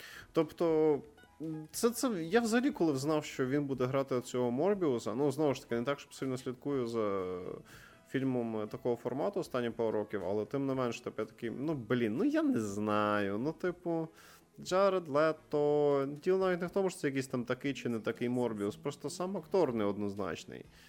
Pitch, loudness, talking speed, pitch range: 135 Hz, -34 LUFS, 180 wpm, 115-160 Hz